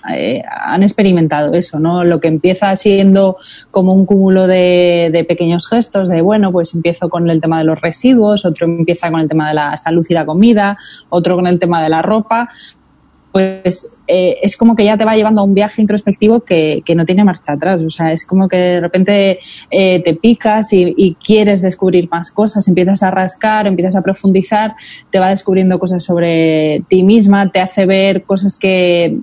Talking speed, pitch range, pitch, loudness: 200 wpm, 170-200 Hz, 185 Hz, -11 LUFS